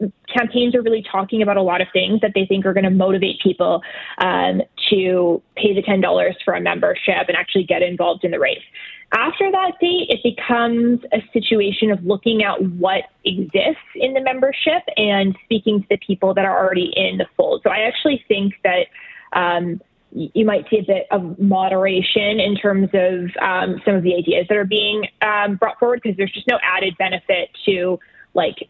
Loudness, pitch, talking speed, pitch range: -18 LUFS, 200 Hz, 195 wpm, 190-225 Hz